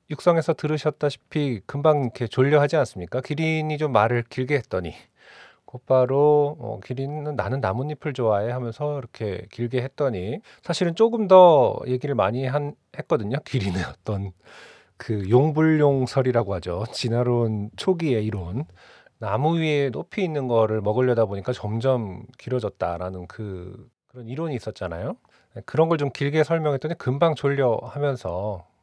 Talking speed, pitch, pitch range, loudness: 320 characters per minute, 130 Hz, 110-150 Hz, -23 LUFS